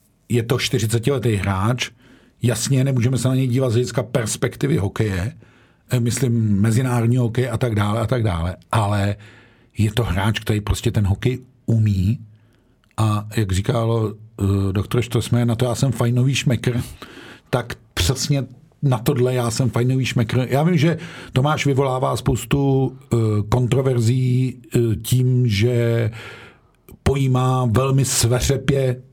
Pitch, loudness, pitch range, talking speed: 120 Hz, -20 LUFS, 110-130 Hz, 130 wpm